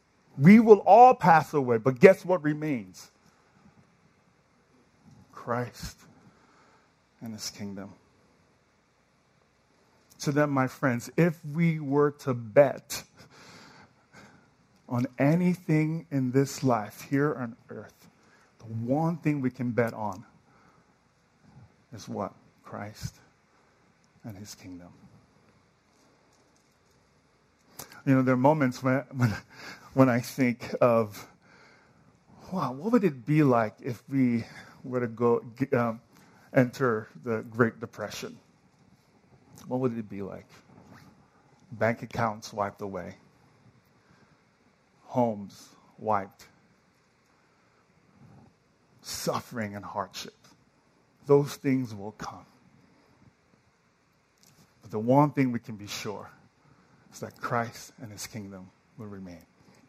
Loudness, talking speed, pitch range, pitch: -26 LUFS, 105 wpm, 110-140 Hz, 125 Hz